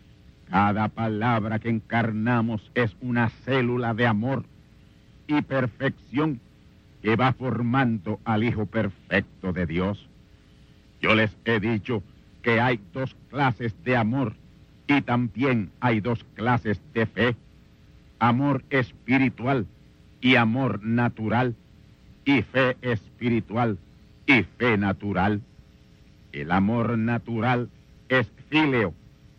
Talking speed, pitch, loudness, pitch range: 105 wpm, 115 Hz, -25 LUFS, 105-125 Hz